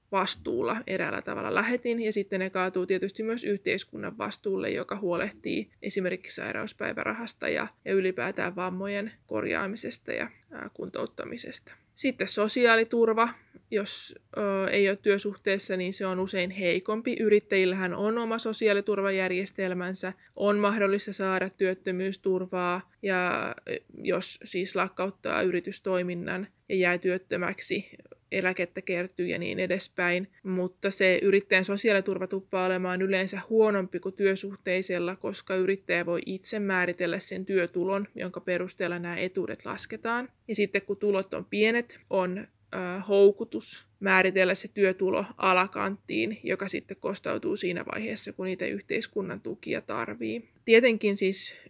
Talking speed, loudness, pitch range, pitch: 120 wpm, -29 LUFS, 185-205 Hz, 190 Hz